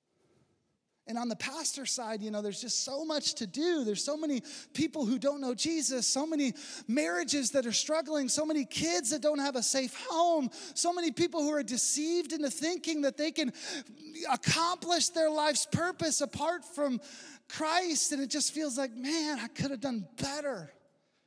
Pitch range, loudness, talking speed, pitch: 265-315 Hz, -31 LUFS, 185 wpm, 290 Hz